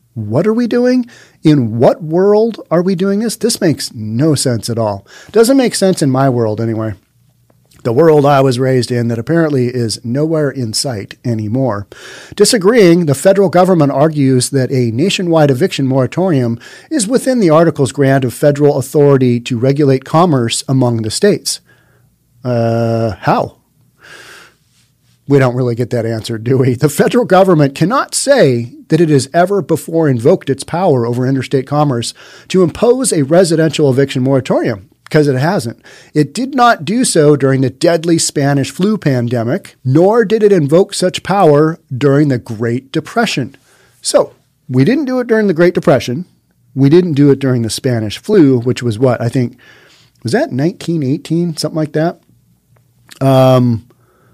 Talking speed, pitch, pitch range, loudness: 160 wpm, 140 Hz, 125-170 Hz, -12 LUFS